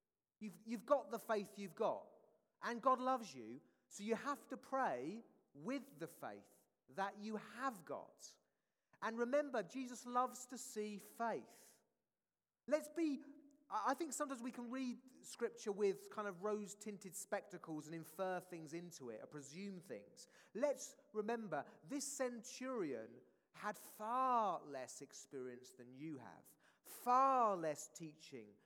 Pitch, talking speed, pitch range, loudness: 220 Hz, 140 wpm, 180-260 Hz, -44 LUFS